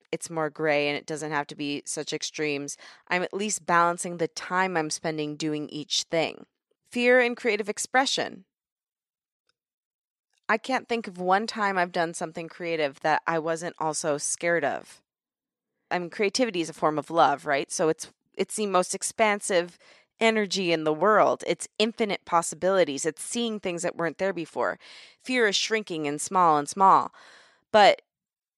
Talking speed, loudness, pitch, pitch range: 165 wpm, -26 LUFS, 175 Hz, 155-210 Hz